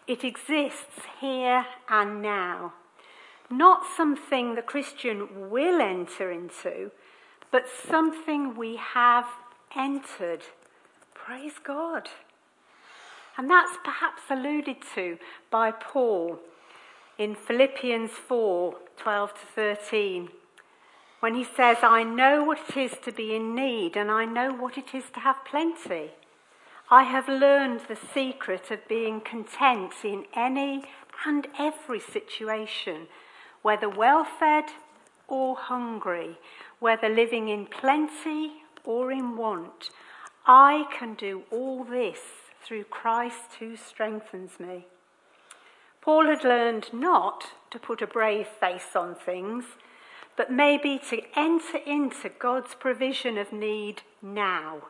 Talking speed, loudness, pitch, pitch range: 120 wpm, -26 LUFS, 245 Hz, 220-280 Hz